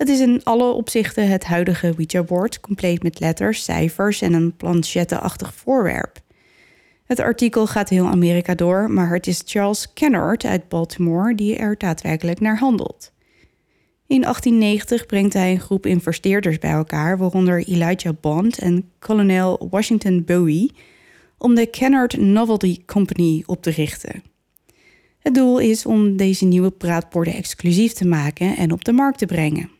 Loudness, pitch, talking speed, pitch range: -18 LUFS, 185 Hz, 150 wpm, 175-225 Hz